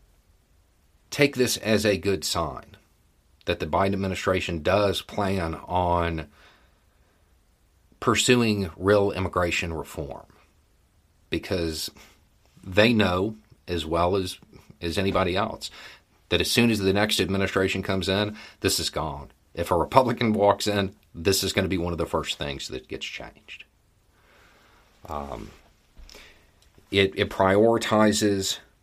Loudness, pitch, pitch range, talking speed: -24 LUFS, 95 Hz, 85-105 Hz, 125 wpm